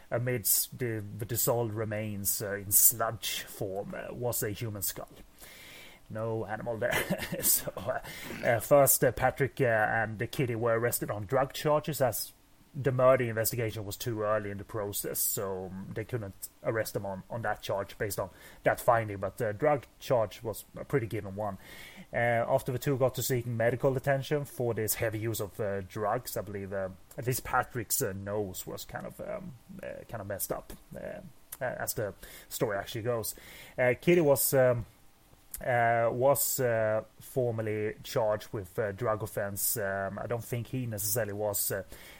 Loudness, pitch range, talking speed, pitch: -30 LUFS, 100-125 Hz, 175 wpm, 115 Hz